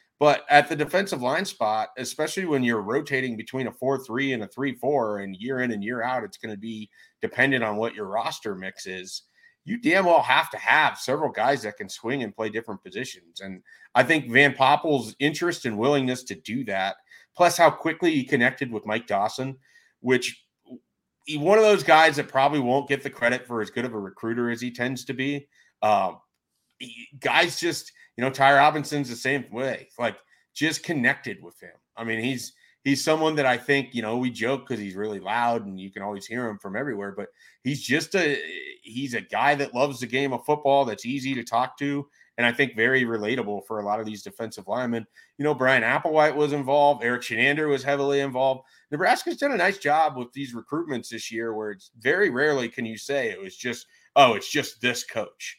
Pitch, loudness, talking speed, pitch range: 130 Hz, -24 LUFS, 210 wpm, 115-145 Hz